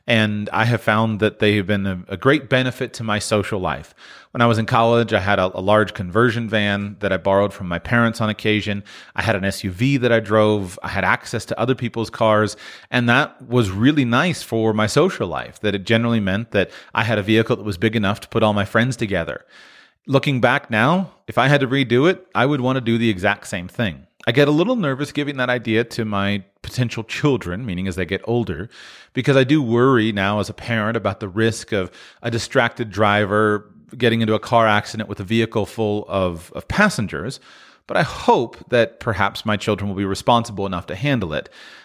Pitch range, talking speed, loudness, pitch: 100-120 Hz, 220 wpm, -19 LUFS, 110 Hz